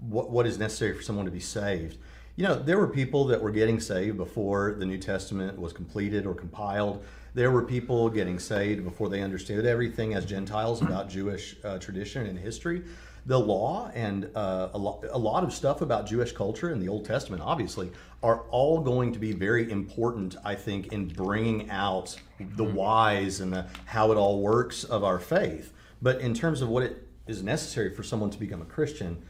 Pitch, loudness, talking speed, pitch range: 105 Hz, -29 LUFS, 195 wpm, 95-115 Hz